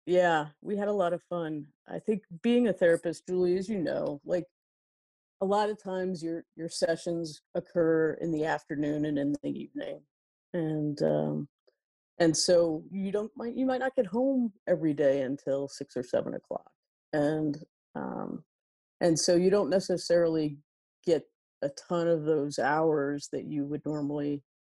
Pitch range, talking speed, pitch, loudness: 150-185 Hz, 165 wpm, 165 Hz, -30 LUFS